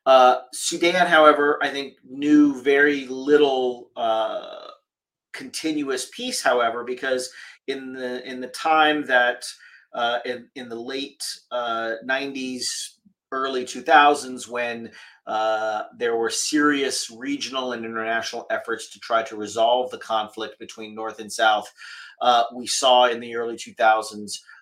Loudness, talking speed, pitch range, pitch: -22 LUFS, 130 wpm, 115-145 Hz, 125 Hz